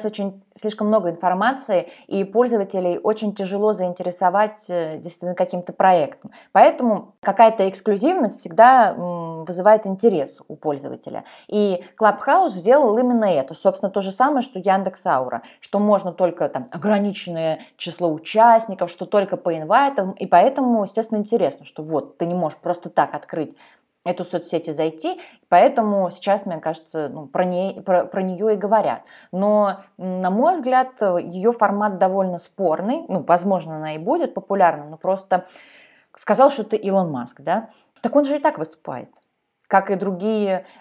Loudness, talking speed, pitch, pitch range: -20 LUFS, 145 wpm, 195 Hz, 175-215 Hz